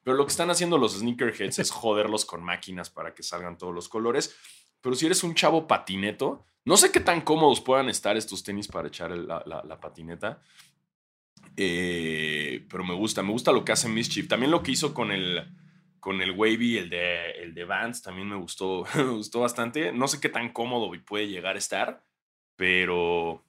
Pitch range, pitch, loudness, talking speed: 90-130 Hz, 105 Hz, -26 LUFS, 200 wpm